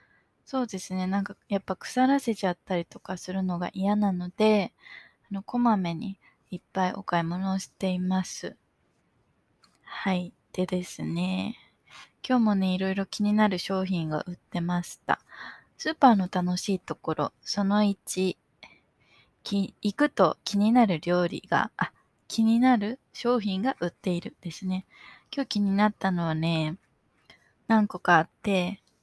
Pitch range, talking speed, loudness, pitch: 180-215 Hz, 275 characters per minute, -27 LUFS, 190 Hz